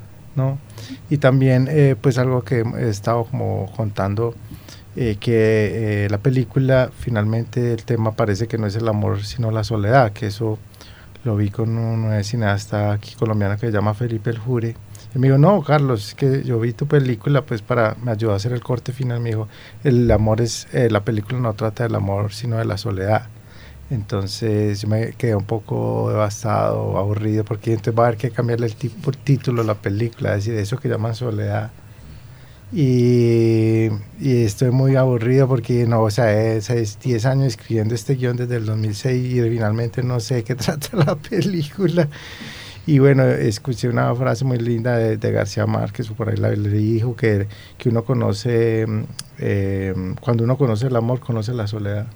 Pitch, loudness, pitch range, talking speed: 115 Hz, -20 LUFS, 110-125 Hz, 185 wpm